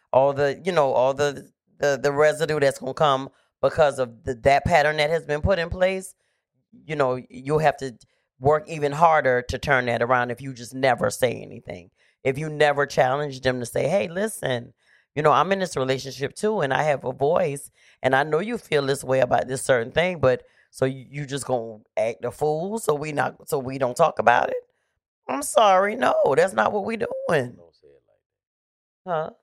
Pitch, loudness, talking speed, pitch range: 145 Hz, -23 LUFS, 210 wpm, 130-160 Hz